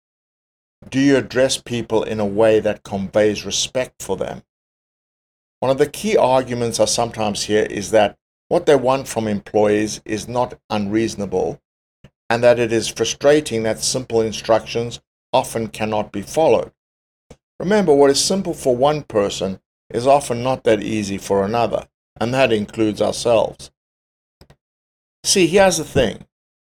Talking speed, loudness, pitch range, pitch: 145 wpm, -18 LUFS, 105-130 Hz, 110 Hz